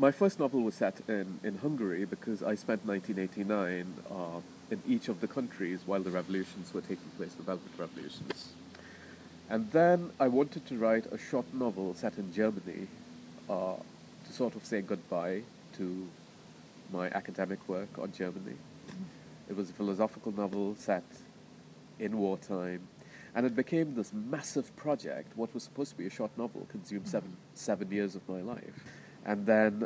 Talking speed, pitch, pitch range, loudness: 165 wpm, 105 Hz, 95-135 Hz, -35 LUFS